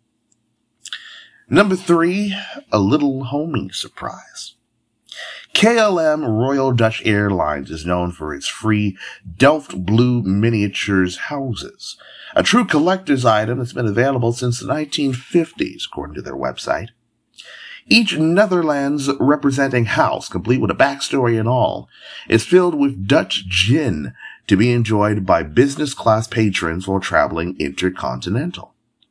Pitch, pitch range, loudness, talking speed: 125 Hz, 105-170 Hz, -17 LUFS, 120 wpm